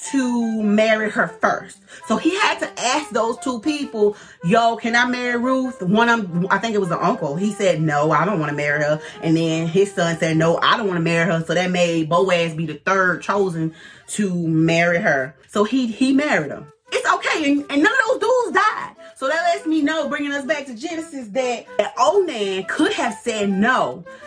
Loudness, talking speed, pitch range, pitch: -19 LUFS, 225 wpm, 175-270 Hz, 215 Hz